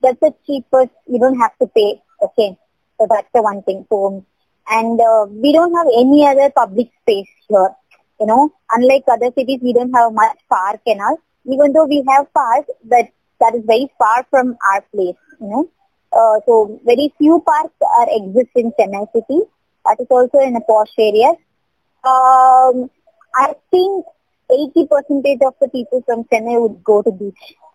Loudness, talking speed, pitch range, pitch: -14 LUFS, 175 wpm, 225-290 Hz, 250 Hz